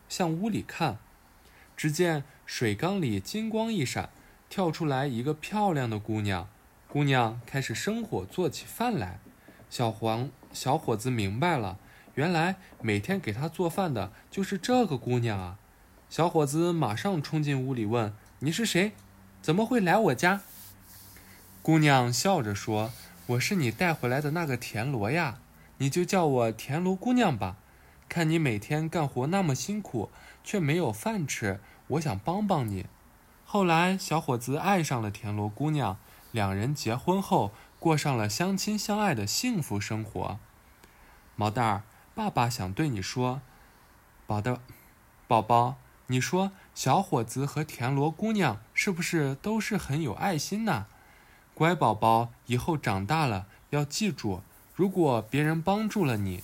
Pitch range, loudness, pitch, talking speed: 110-170 Hz, -29 LUFS, 135 Hz, 215 characters per minute